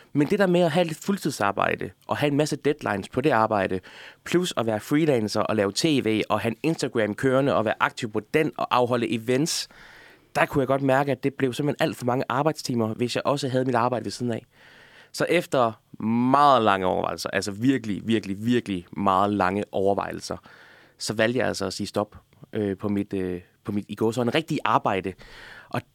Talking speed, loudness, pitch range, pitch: 210 wpm, -24 LUFS, 105-140 Hz, 115 Hz